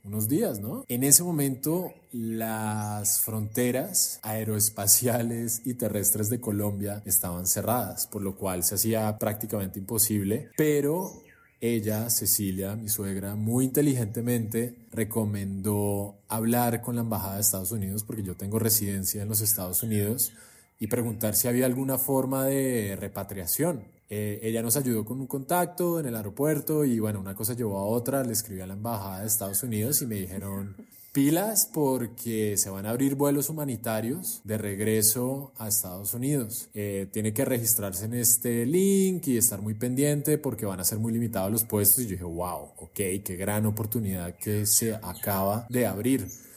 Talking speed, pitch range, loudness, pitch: 160 wpm, 105-125 Hz, -27 LUFS, 110 Hz